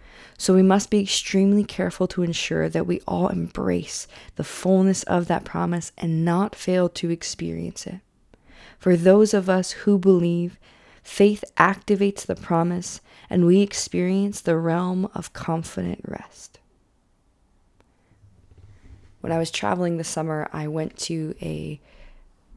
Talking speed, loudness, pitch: 135 wpm, -22 LUFS, 170 Hz